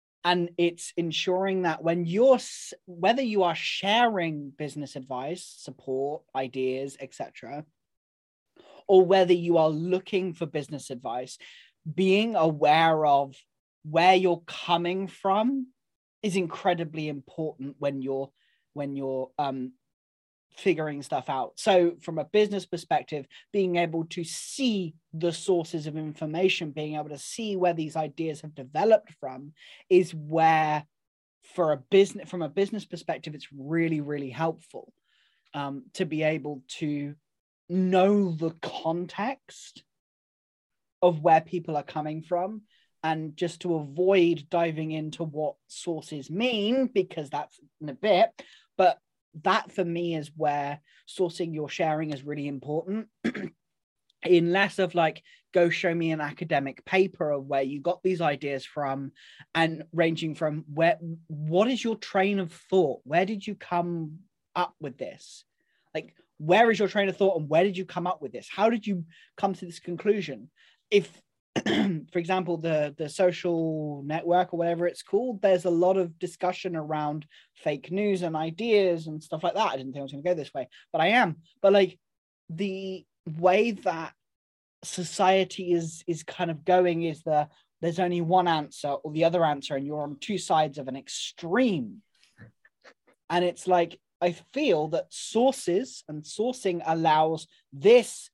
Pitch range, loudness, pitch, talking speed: 150-185 Hz, -27 LUFS, 170 Hz, 155 wpm